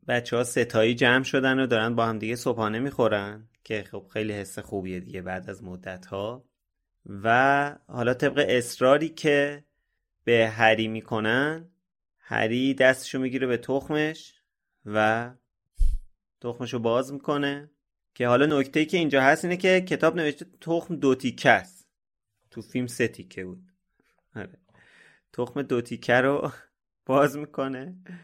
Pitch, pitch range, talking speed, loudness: 125 Hz, 110-140 Hz, 140 wpm, -25 LUFS